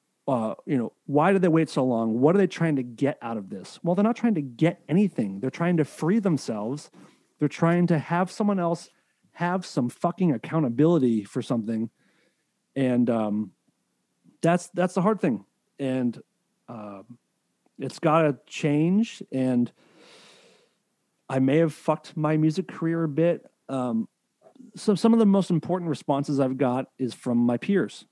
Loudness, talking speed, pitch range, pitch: -25 LUFS, 170 wpm, 130-180 Hz, 155 Hz